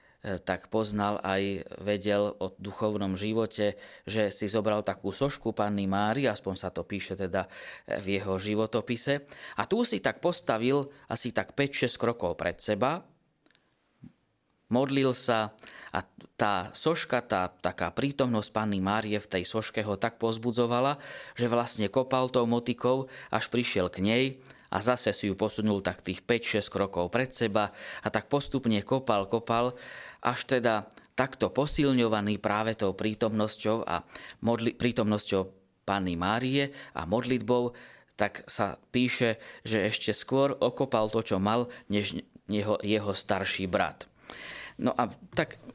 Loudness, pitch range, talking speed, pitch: -30 LUFS, 100-125 Hz, 140 wpm, 110 Hz